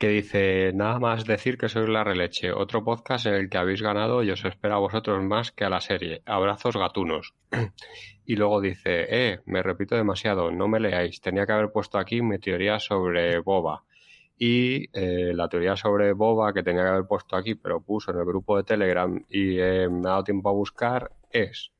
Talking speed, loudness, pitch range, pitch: 205 wpm, -25 LUFS, 95-110 Hz, 100 Hz